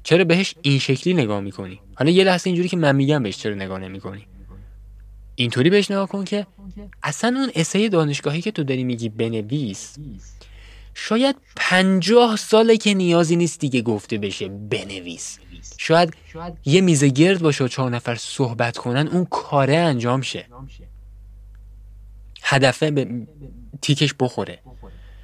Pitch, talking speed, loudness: 135 Hz, 140 wpm, -19 LUFS